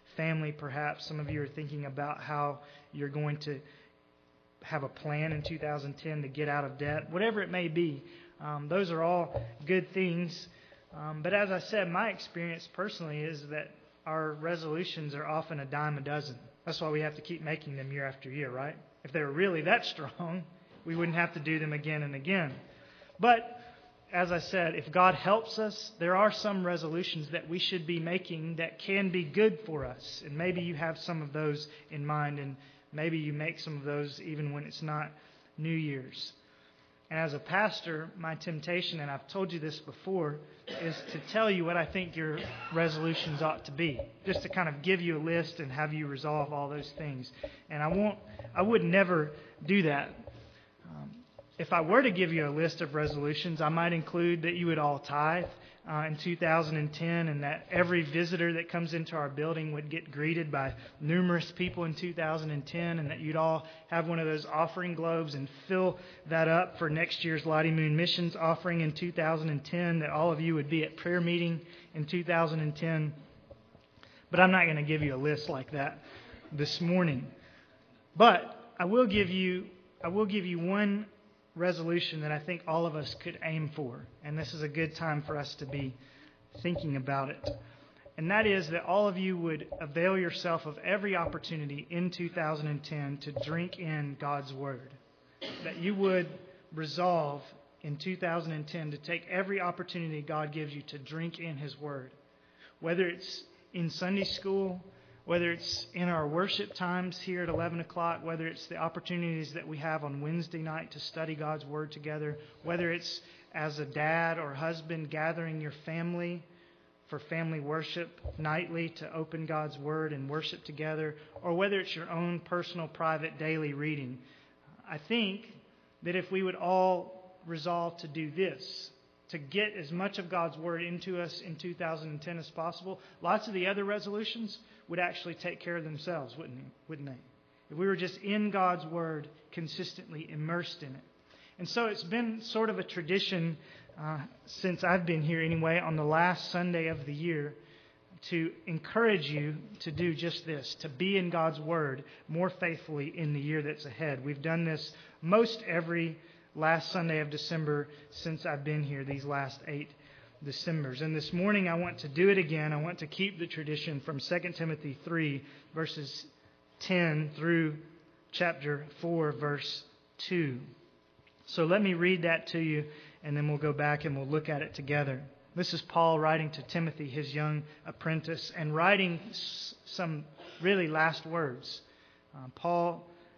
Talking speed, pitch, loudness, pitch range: 180 wpm, 160 Hz, -33 LUFS, 150-175 Hz